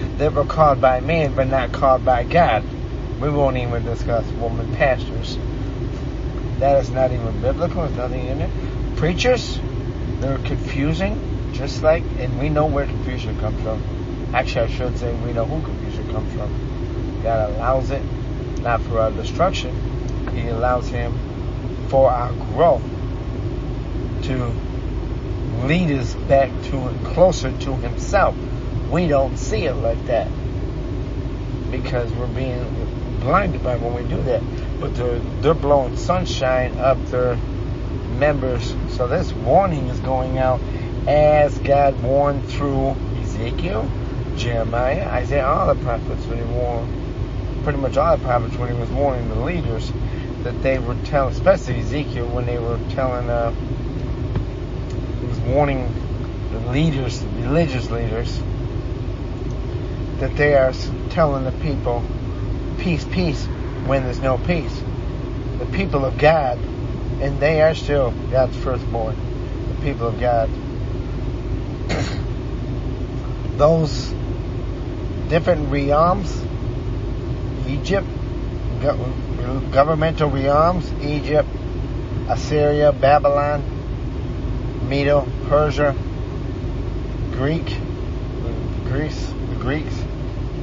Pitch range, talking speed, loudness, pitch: 115-135 Hz, 120 wpm, -21 LUFS, 125 Hz